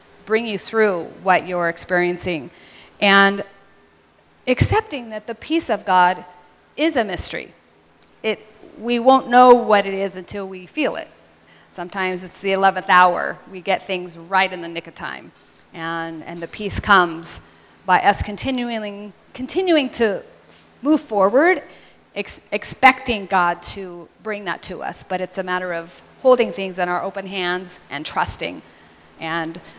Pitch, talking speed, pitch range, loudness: 190 Hz, 150 wpm, 175-220 Hz, -19 LUFS